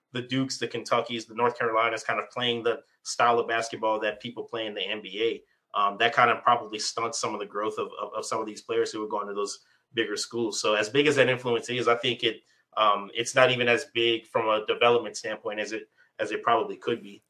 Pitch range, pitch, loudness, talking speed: 110-125 Hz, 120 Hz, -27 LUFS, 245 wpm